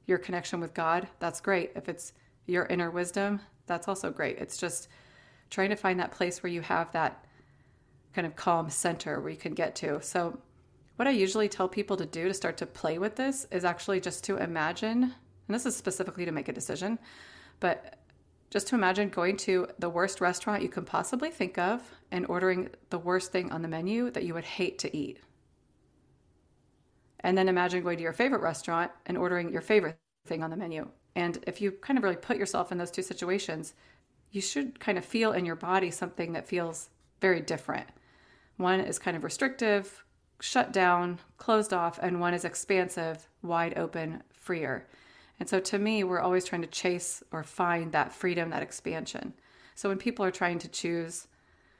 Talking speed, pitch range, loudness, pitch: 195 wpm, 170-195 Hz, -31 LUFS, 180 Hz